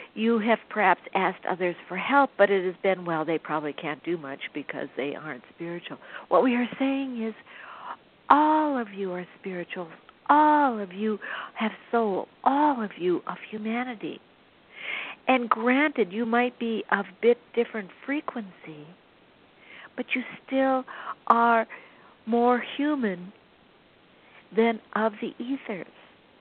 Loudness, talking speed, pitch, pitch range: -26 LUFS, 140 wpm, 225 Hz, 190-255 Hz